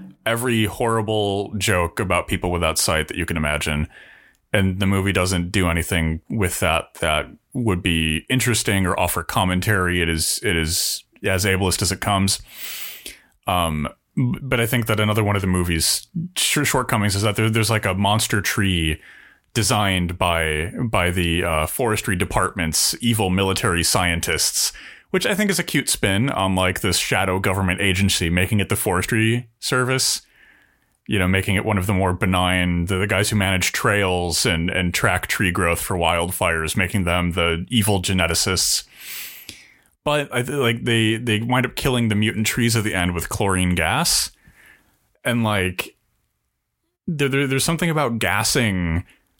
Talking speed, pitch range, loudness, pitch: 165 wpm, 90-115 Hz, -20 LUFS, 100 Hz